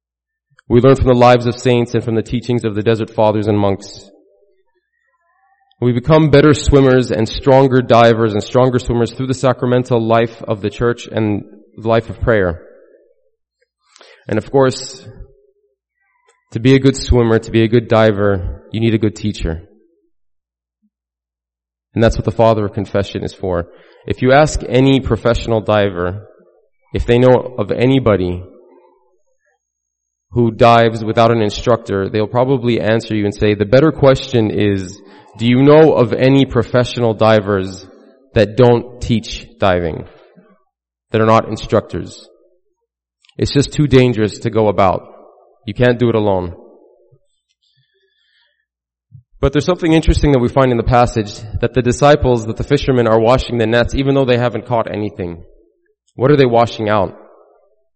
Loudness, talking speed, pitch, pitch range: -14 LUFS, 155 wpm, 115 Hz, 105-135 Hz